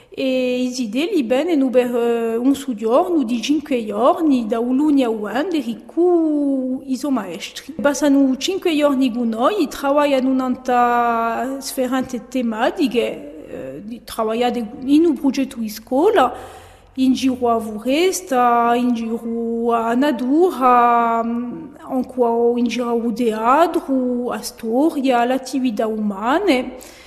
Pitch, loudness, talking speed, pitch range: 255 Hz, -18 LUFS, 115 wpm, 235-280 Hz